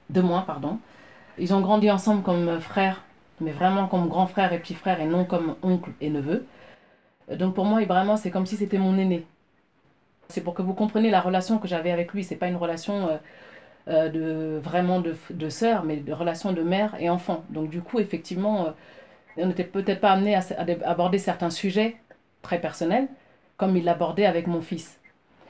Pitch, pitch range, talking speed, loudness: 180 Hz, 170-195 Hz, 195 wpm, -25 LUFS